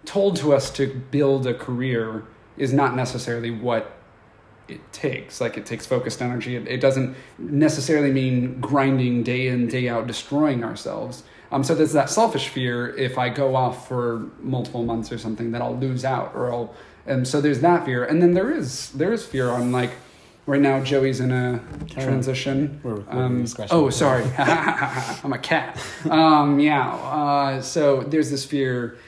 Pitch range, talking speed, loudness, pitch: 125-140 Hz, 175 wpm, -22 LUFS, 130 Hz